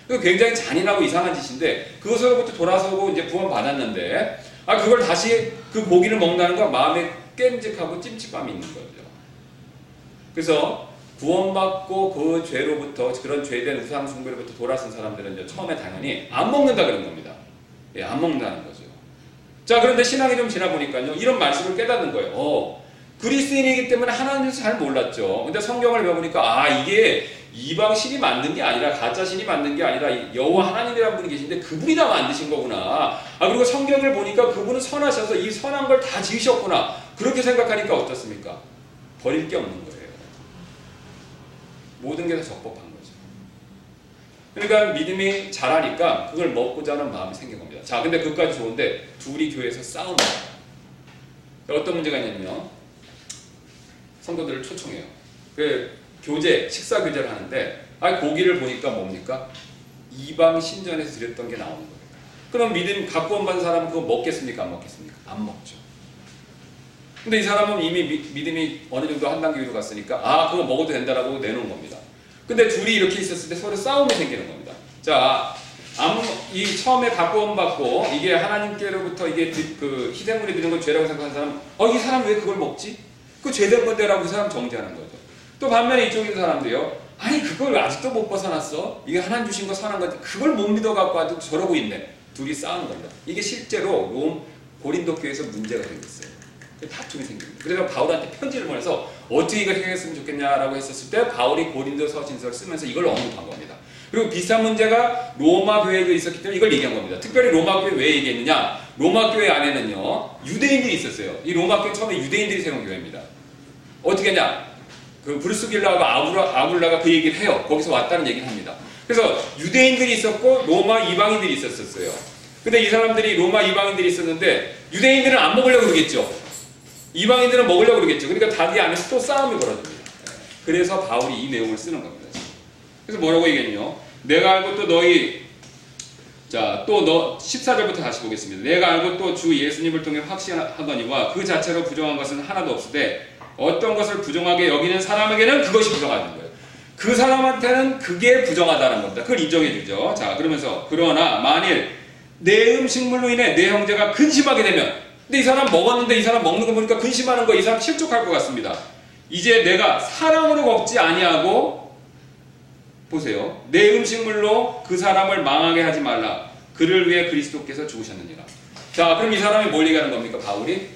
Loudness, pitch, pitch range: -20 LUFS, 195 Hz, 160-245 Hz